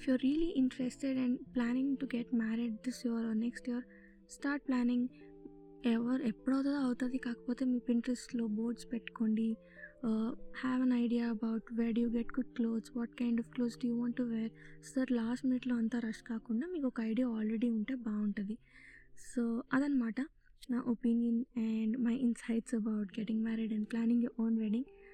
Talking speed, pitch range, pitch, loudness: 160 wpm, 225-255 Hz, 235 Hz, -36 LUFS